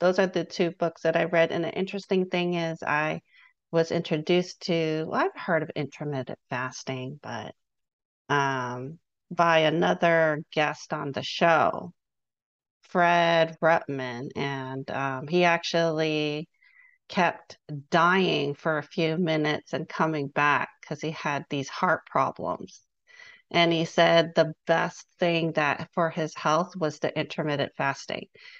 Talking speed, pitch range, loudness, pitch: 135 wpm, 145-170 Hz, -26 LUFS, 160 Hz